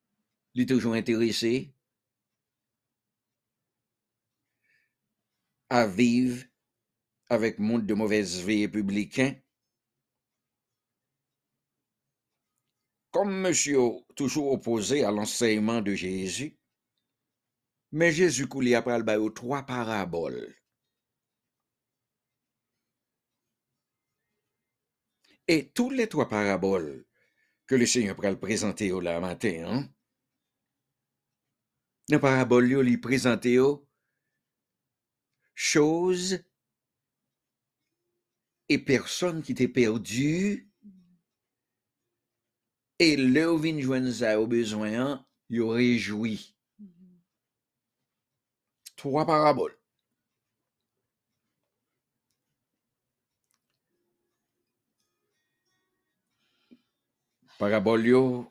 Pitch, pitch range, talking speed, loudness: 125 Hz, 115-140 Hz, 65 wpm, -26 LUFS